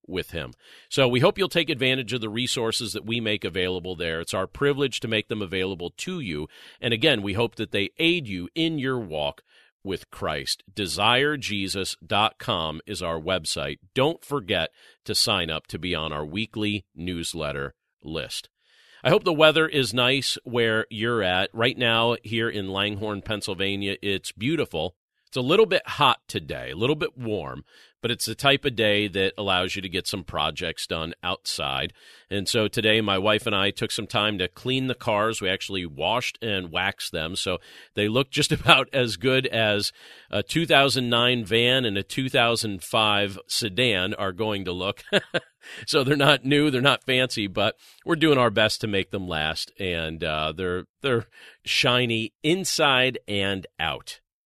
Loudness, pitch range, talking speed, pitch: -24 LUFS, 95-125 Hz, 175 wpm, 110 Hz